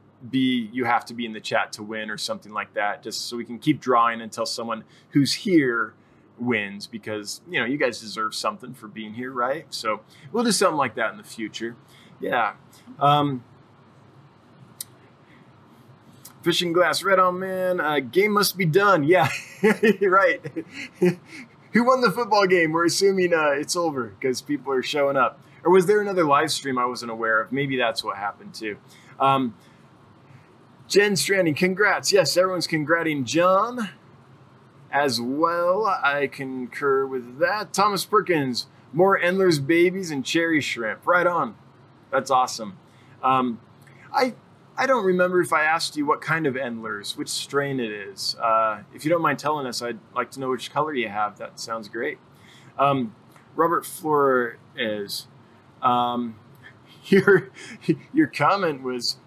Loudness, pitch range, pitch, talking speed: -23 LUFS, 120-180 Hz, 140 Hz, 160 wpm